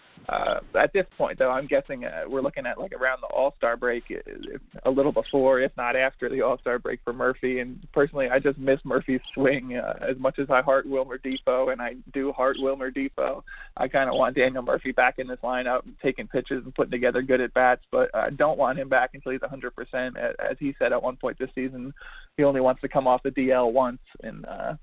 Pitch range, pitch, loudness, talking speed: 125-135 Hz, 130 Hz, -25 LUFS, 235 wpm